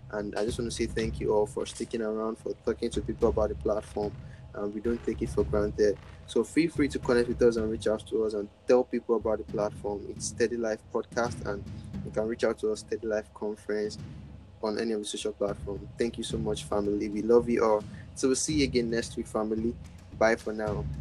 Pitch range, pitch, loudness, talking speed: 105-115 Hz, 110 Hz, -30 LUFS, 245 wpm